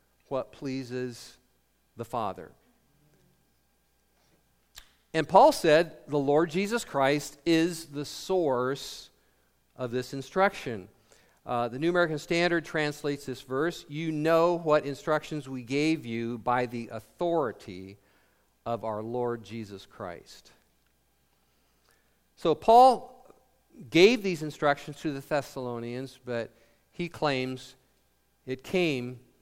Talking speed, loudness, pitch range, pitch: 110 wpm, -28 LUFS, 115-155 Hz, 135 Hz